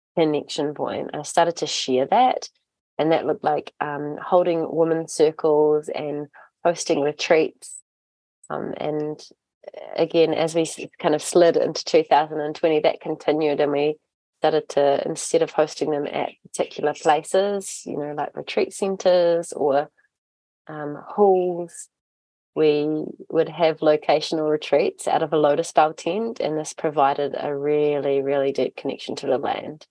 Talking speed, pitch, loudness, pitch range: 140 wpm, 155 Hz, -22 LUFS, 145-165 Hz